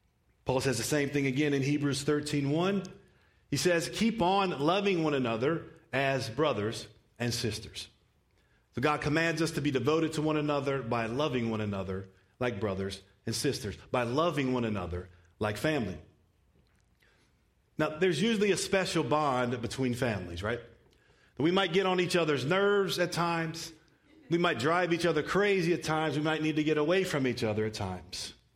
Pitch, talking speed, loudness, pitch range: 150 Hz, 170 wpm, -30 LUFS, 115-165 Hz